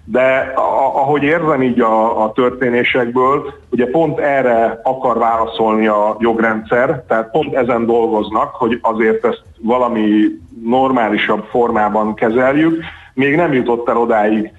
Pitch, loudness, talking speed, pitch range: 115 Hz, -14 LUFS, 125 wpm, 110-130 Hz